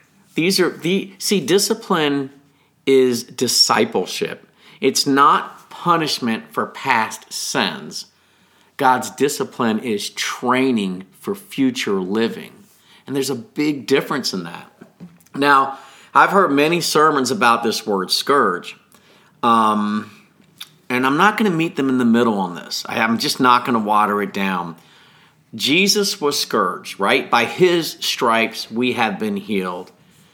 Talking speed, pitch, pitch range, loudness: 135 wpm, 145 Hz, 120-195 Hz, -18 LUFS